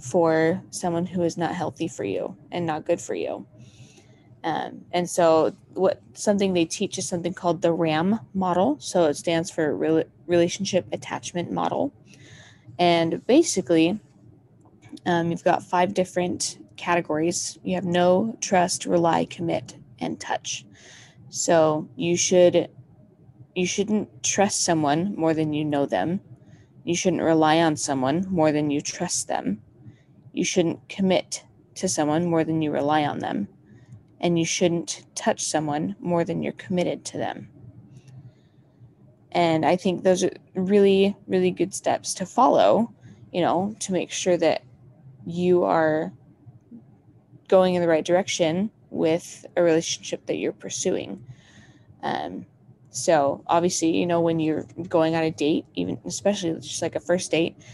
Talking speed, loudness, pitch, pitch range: 150 wpm, -24 LUFS, 170 Hz, 155-180 Hz